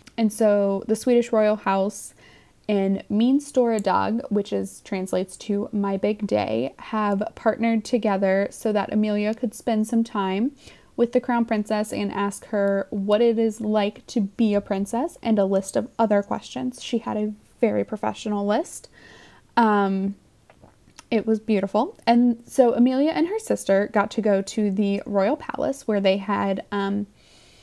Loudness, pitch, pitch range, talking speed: -23 LUFS, 210 Hz, 200-230 Hz, 160 wpm